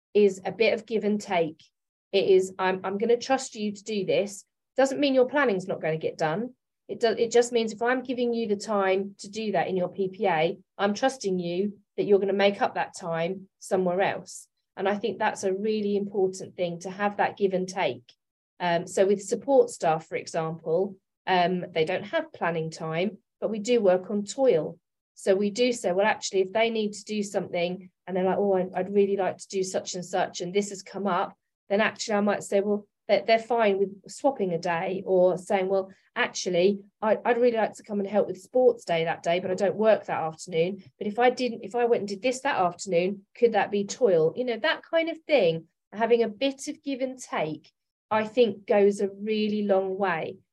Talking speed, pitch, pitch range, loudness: 225 wpm, 200 Hz, 185-225 Hz, -26 LUFS